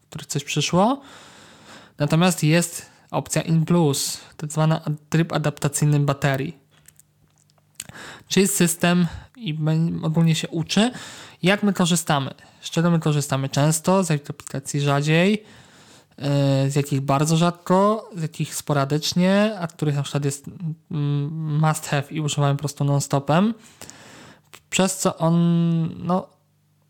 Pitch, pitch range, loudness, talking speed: 155 Hz, 145-175 Hz, -22 LUFS, 125 wpm